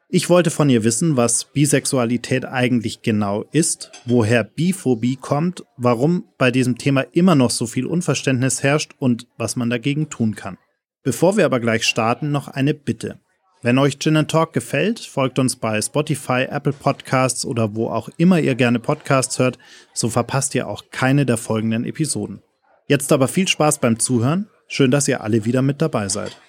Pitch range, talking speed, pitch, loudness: 120-150 Hz, 175 wpm, 130 Hz, -19 LUFS